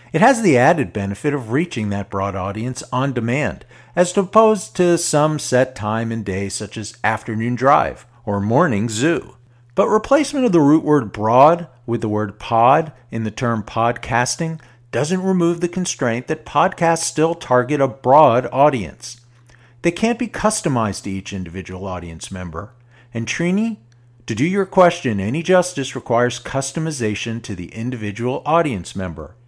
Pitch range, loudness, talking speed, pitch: 110-165 Hz, -18 LUFS, 155 wpm, 125 Hz